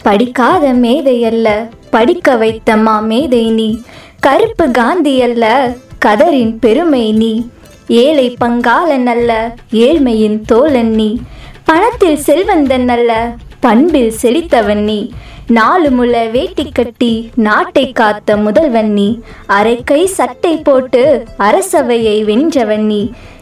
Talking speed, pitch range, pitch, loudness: 90 wpm, 225-280 Hz, 240 Hz, -10 LUFS